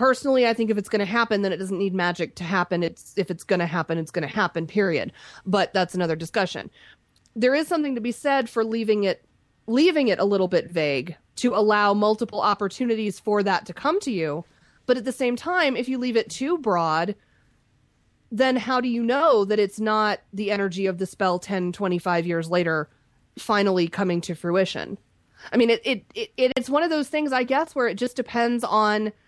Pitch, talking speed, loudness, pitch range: 210 Hz, 215 wpm, -23 LUFS, 180-250 Hz